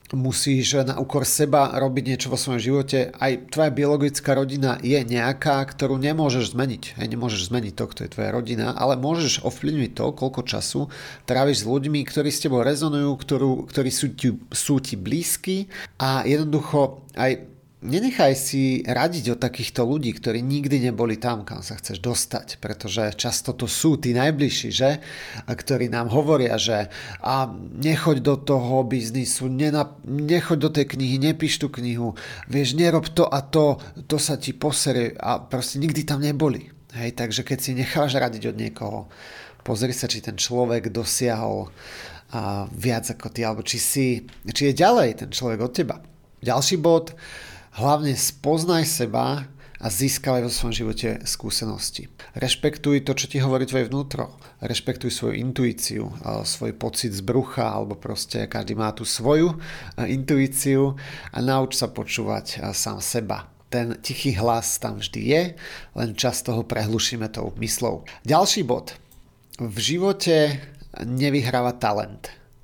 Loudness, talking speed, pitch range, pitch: -23 LUFS, 150 wpm, 120-145 Hz, 130 Hz